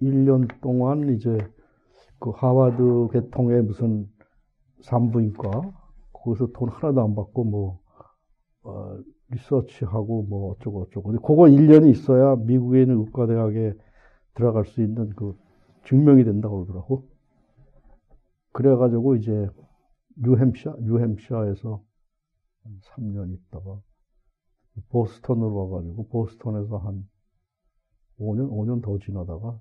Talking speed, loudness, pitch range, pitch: 240 characters per minute, -21 LUFS, 105-130 Hz, 115 Hz